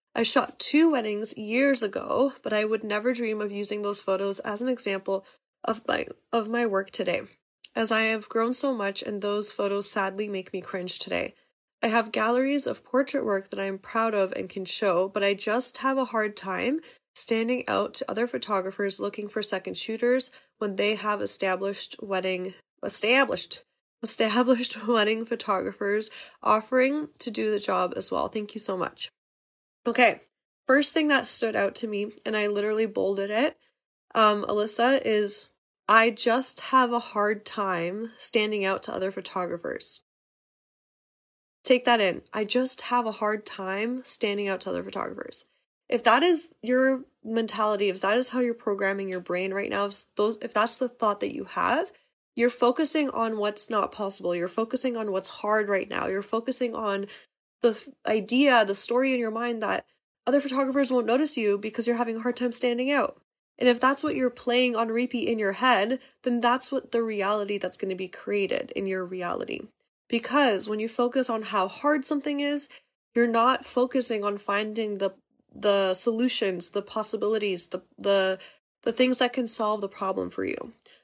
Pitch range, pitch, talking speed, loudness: 200-250 Hz, 220 Hz, 180 wpm, -26 LUFS